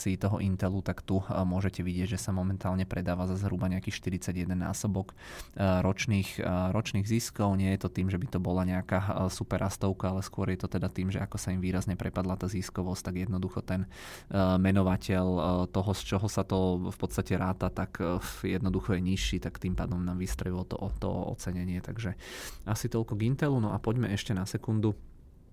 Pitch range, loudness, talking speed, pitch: 90-100 Hz, -31 LUFS, 185 wpm, 95 Hz